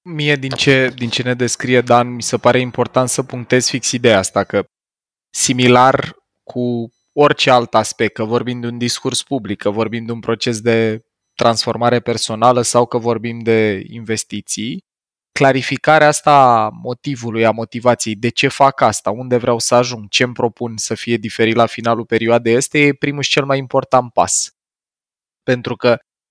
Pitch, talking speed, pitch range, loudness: 120 Hz, 170 wpm, 115-130 Hz, -15 LUFS